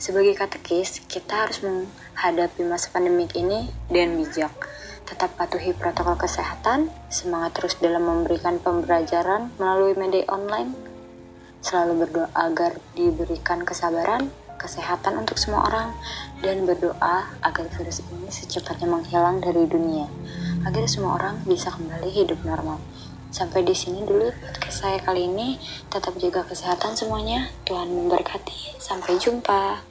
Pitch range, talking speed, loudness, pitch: 170-190 Hz, 125 wpm, -24 LUFS, 175 Hz